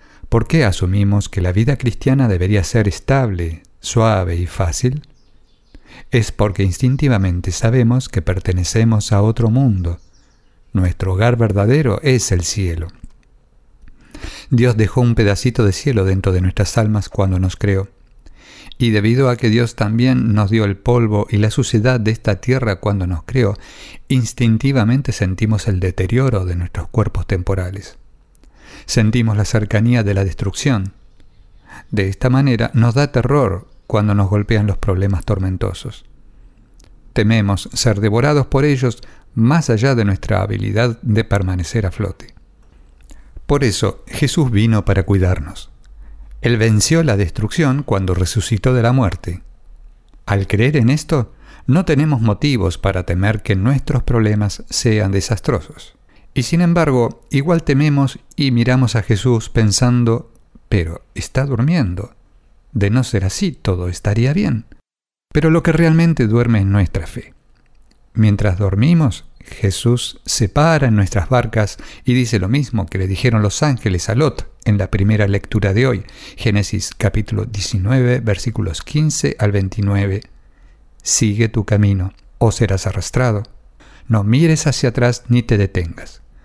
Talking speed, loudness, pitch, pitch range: 140 wpm, -16 LUFS, 110 Hz, 100-125 Hz